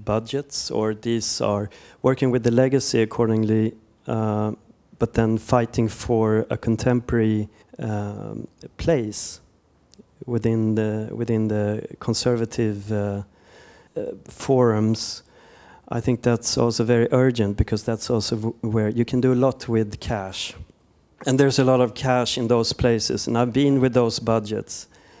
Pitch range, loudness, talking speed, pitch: 110-125 Hz, -22 LUFS, 140 wpm, 115 Hz